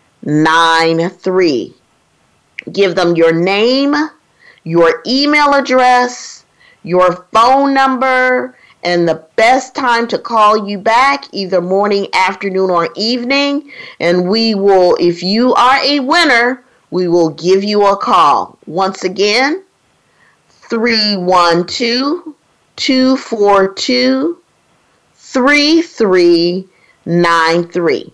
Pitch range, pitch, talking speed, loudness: 180-260 Hz, 210 Hz, 110 wpm, -12 LUFS